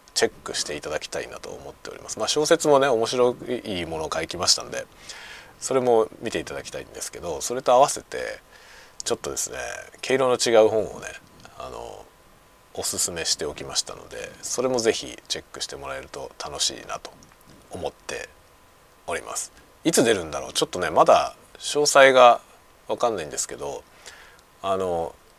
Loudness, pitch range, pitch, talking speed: -23 LUFS, 95-130 Hz, 120 Hz, 355 characters per minute